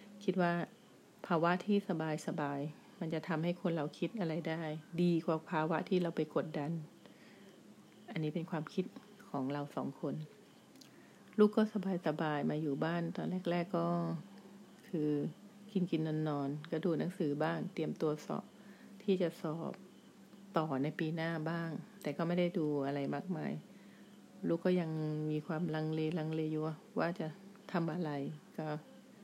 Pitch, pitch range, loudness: 165 Hz, 155-185 Hz, -37 LUFS